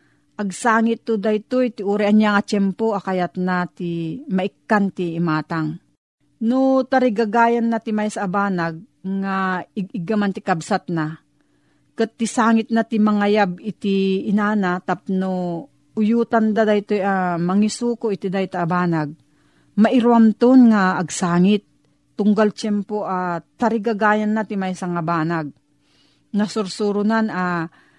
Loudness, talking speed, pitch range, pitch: -20 LUFS, 130 wpm, 180-220 Hz, 200 Hz